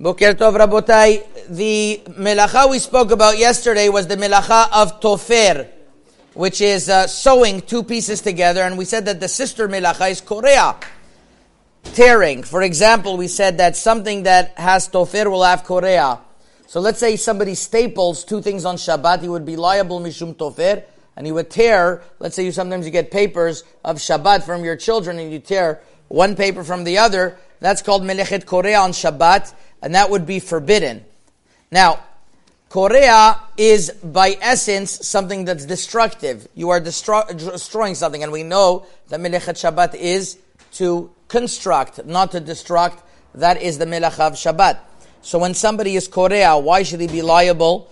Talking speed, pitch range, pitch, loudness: 165 wpm, 175-210 Hz, 185 Hz, -15 LUFS